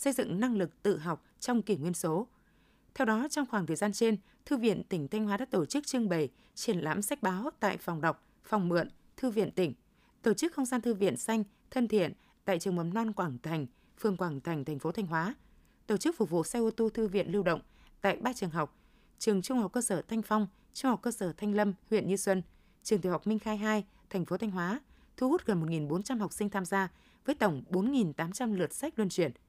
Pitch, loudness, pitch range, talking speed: 205 Hz, -33 LUFS, 180-230 Hz, 240 wpm